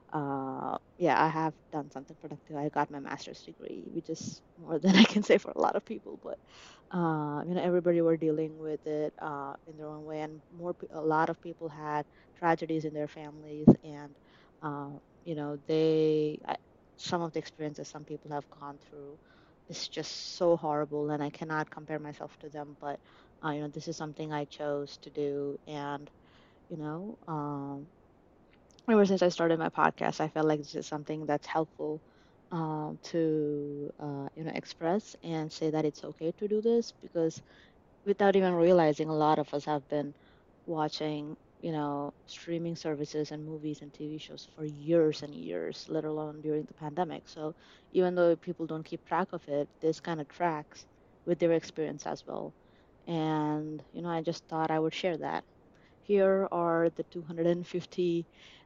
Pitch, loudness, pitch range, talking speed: 155 Hz, -32 LUFS, 150-165 Hz, 185 wpm